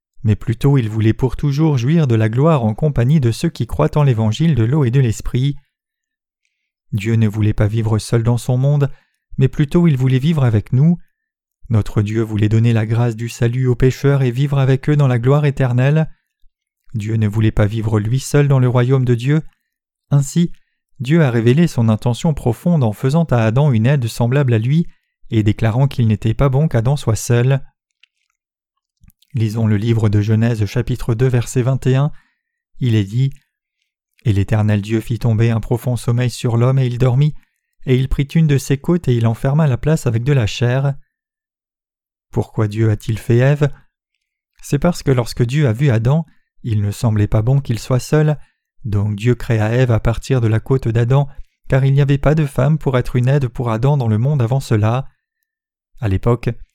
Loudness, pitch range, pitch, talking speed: -16 LUFS, 115-145 Hz, 125 Hz, 195 wpm